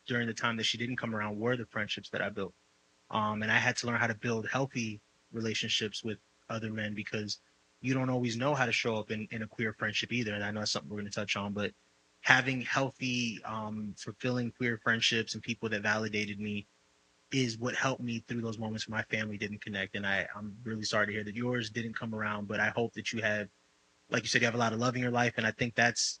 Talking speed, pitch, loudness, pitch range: 255 wpm, 110 Hz, -33 LUFS, 105-120 Hz